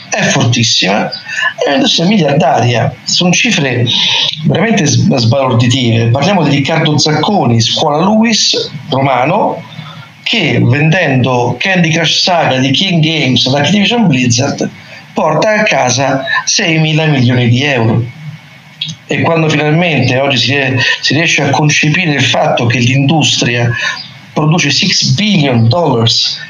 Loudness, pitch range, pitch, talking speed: -10 LUFS, 130-165 Hz, 150 Hz, 120 wpm